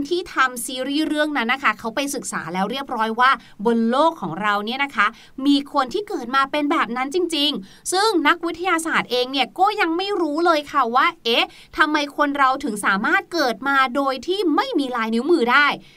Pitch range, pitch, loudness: 250-330 Hz, 280 Hz, -20 LUFS